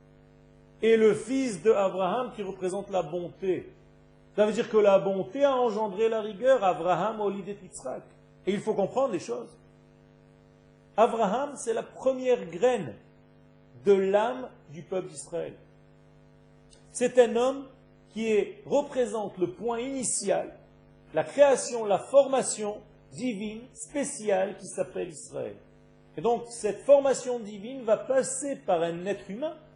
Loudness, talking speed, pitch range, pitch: -27 LUFS, 140 wpm, 195-255 Hz, 220 Hz